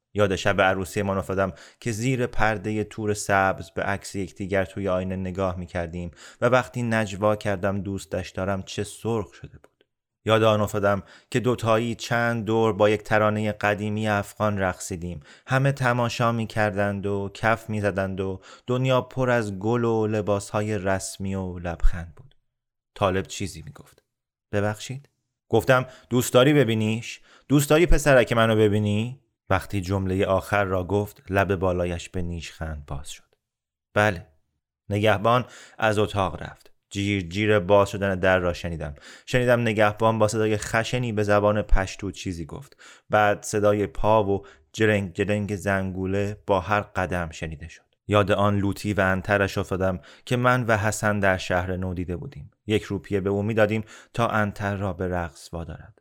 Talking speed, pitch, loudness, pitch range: 155 wpm, 105 Hz, -24 LUFS, 95-110 Hz